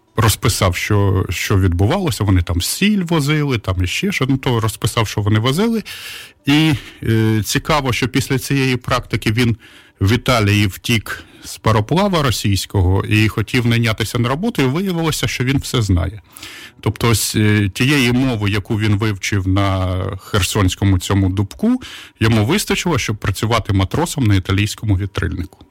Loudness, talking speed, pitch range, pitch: -17 LUFS, 145 wpm, 100-130 Hz, 110 Hz